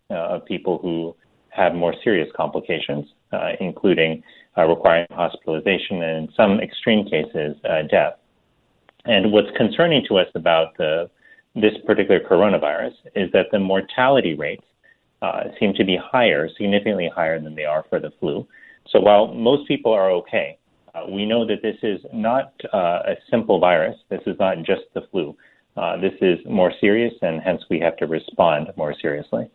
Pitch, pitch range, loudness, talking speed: 95 Hz, 80-110 Hz, -20 LUFS, 170 wpm